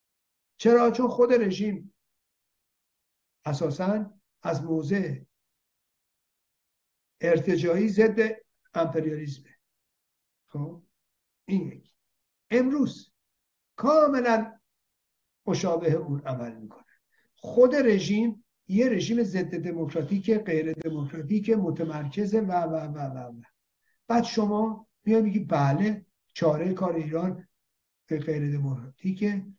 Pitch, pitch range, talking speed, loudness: 185 Hz, 160-220 Hz, 85 wpm, -26 LUFS